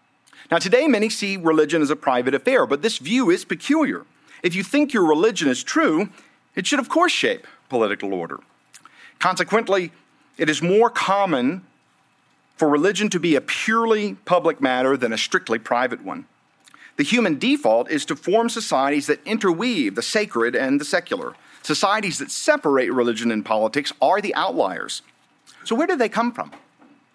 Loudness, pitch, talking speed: -20 LUFS, 215 Hz, 165 wpm